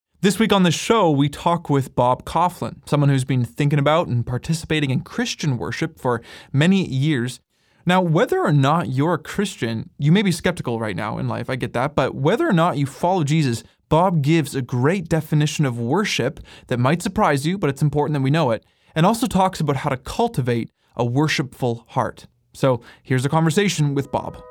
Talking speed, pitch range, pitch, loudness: 200 wpm, 130-170 Hz, 150 Hz, -20 LUFS